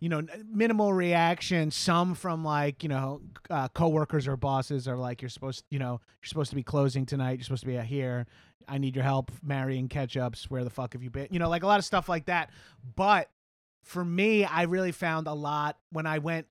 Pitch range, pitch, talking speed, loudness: 130-170 Hz, 145 Hz, 230 wpm, -29 LUFS